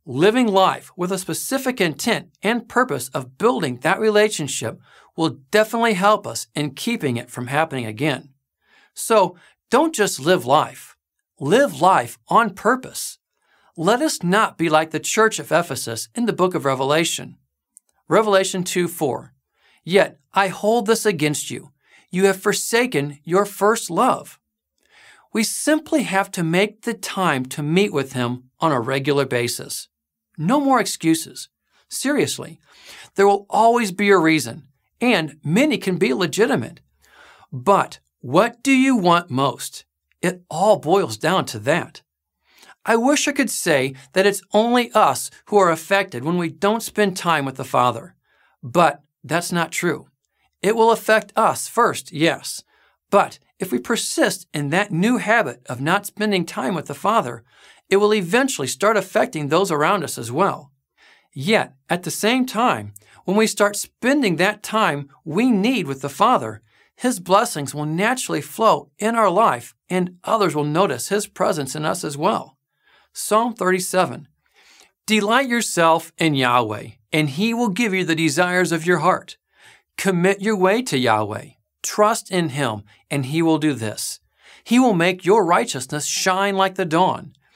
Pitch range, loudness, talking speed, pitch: 150-215 Hz, -19 LUFS, 155 wpm, 185 Hz